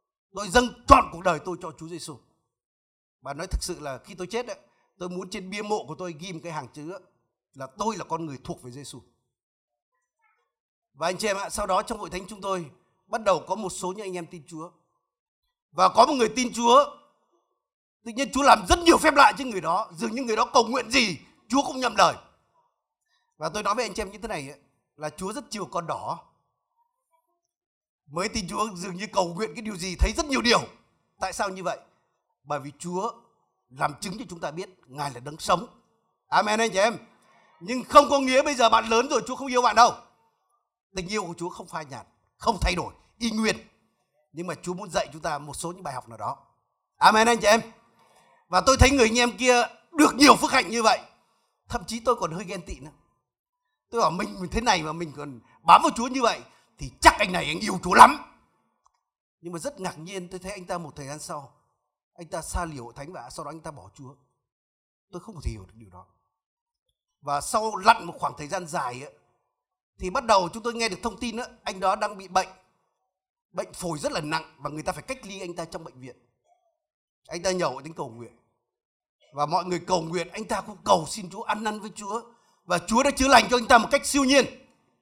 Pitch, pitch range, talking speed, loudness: 190 Hz, 160-235 Hz, 235 wpm, -24 LUFS